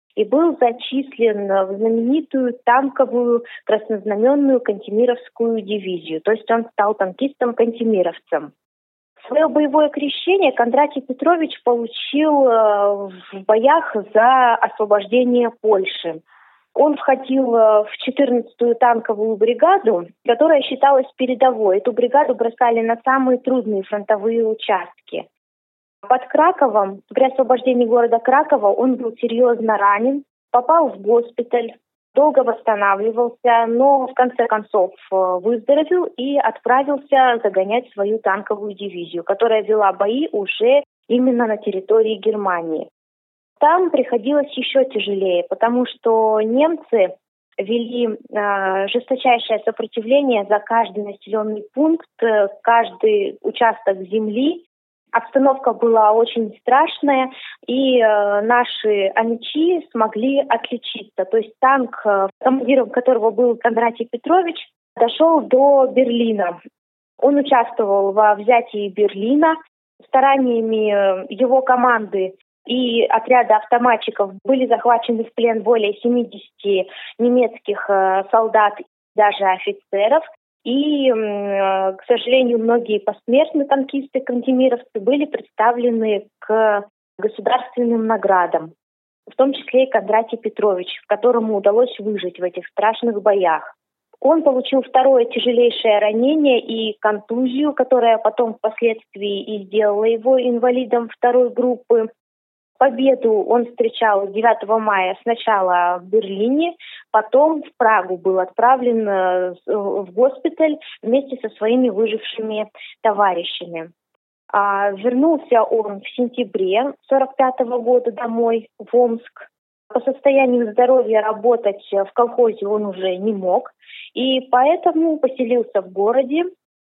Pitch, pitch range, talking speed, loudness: 235 Hz, 215-260 Hz, 105 wpm, -17 LUFS